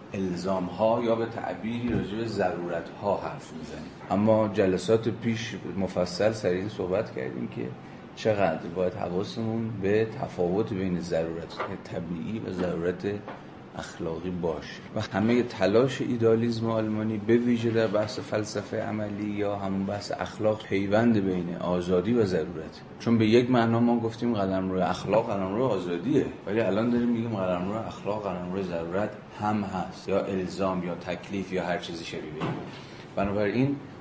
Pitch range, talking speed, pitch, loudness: 90-115 Hz, 150 wpm, 100 Hz, -28 LUFS